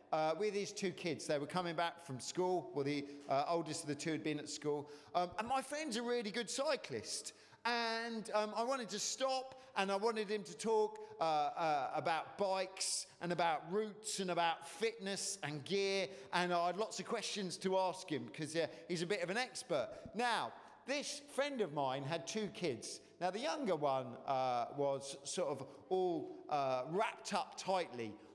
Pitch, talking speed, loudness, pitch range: 190 Hz, 195 wpm, -39 LUFS, 155-220 Hz